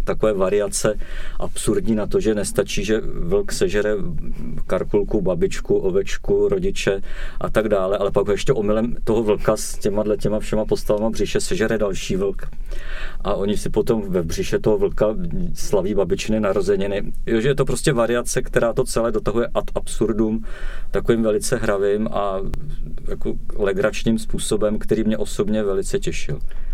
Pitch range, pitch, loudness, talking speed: 100-155 Hz, 110 Hz, -21 LUFS, 150 wpm